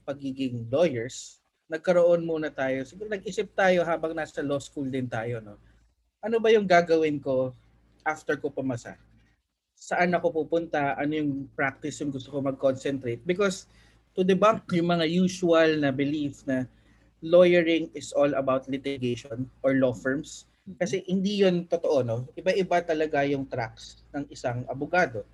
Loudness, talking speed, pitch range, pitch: -26 LUFS, 145 wpm, 130-175 Hz, 145 Hz